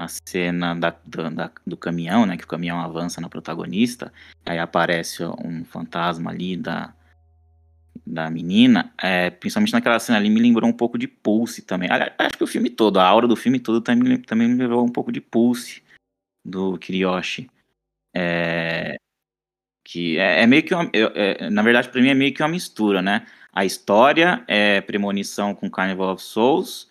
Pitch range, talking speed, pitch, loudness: 85-125 Hz, 180 wpm, 100 Hz, -20 LUFS